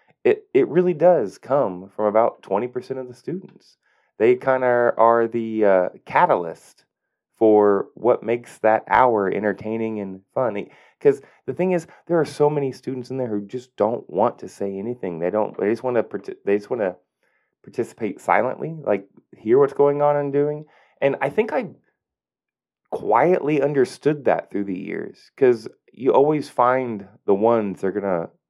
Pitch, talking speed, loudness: 130 Hz, 175 wpm, -21 LUFS